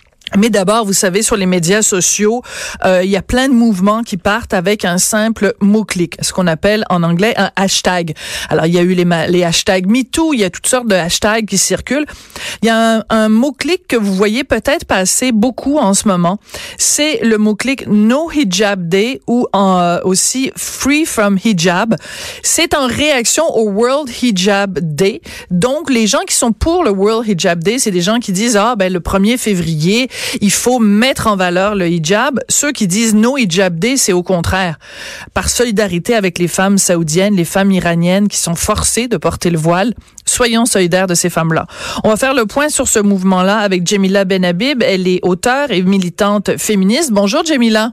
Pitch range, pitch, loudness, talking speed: 185-235 Hz, 205 Hz, -12 LUFS, 200 wpm